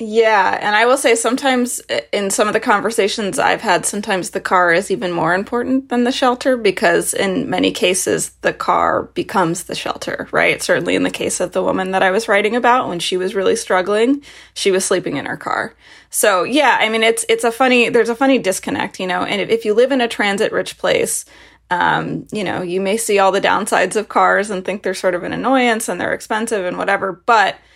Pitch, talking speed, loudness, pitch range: 215 Hz, 225 wpm, -16 LUFS, 190-240 Hz